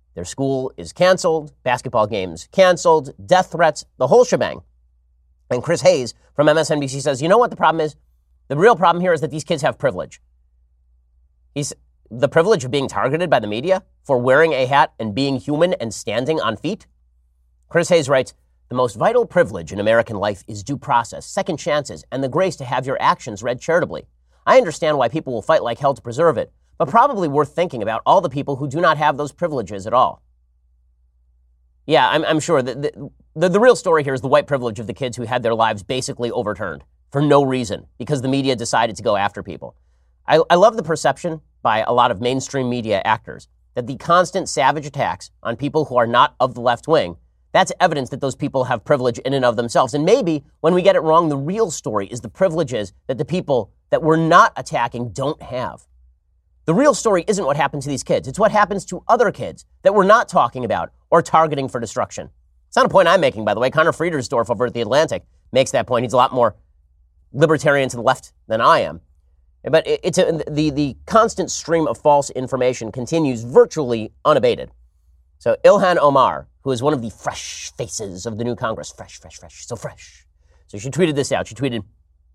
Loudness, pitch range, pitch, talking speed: -18 LUFS, 95-155 Hz, 130 Hz, 210 wpm